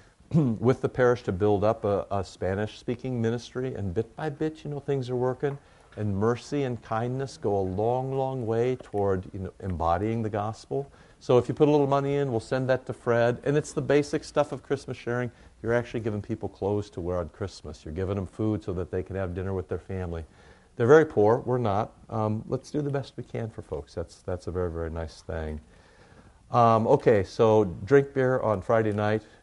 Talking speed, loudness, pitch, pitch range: 215 wpm, -27 LUFS, 115 Hz, 100-130 Hz